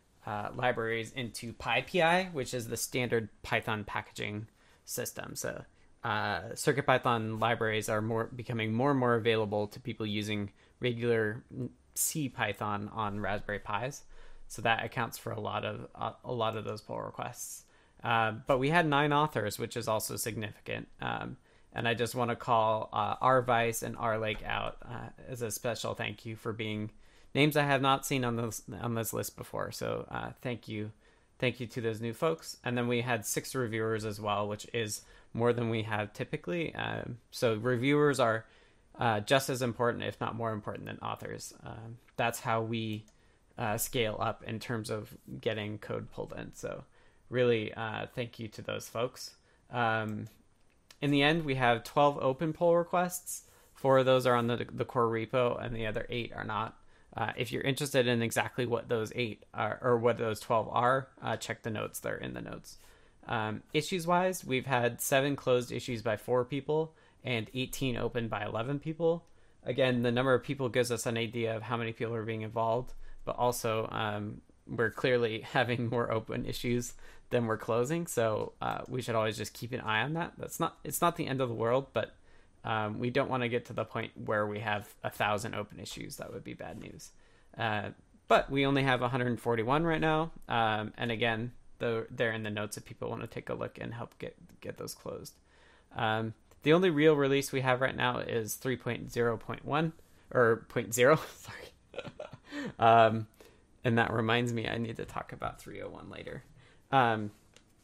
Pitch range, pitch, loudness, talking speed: 110-130 Hz, 115 Hz, -32 LUFS, 195 wpm